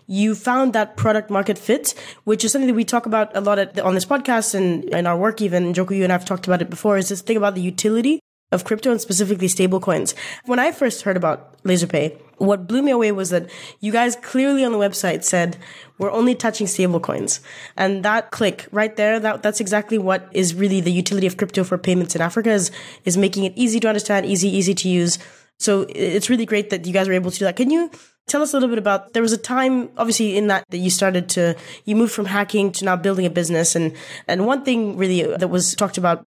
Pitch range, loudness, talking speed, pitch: 185-225 Hz, -19 LUFS, 245 wpm, 200 Hz